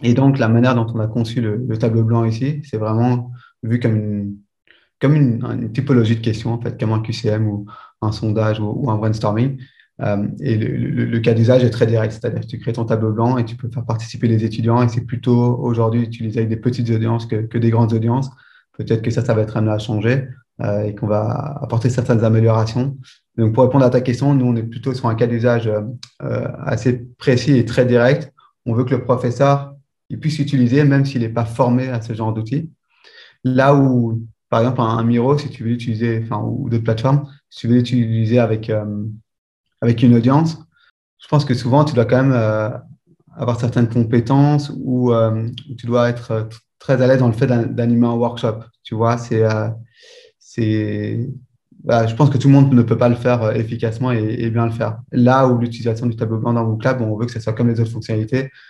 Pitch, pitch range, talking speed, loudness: 120 Hz, 115-130 Hz, 225 wpm, -17 LUFS